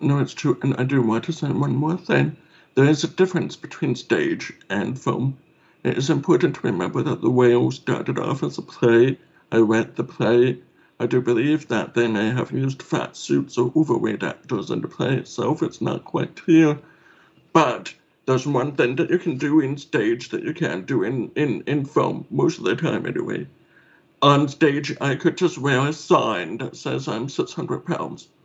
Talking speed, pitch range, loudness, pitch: 200 wpm, 120-155 Hz, -22 LUFS, 140 Hz